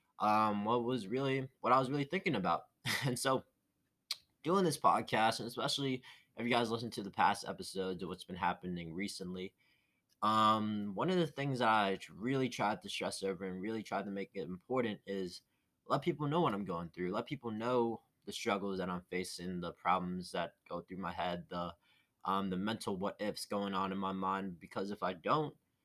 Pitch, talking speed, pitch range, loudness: 105 Hz, 200 wpm, 95-125 Hz, -37 LUFS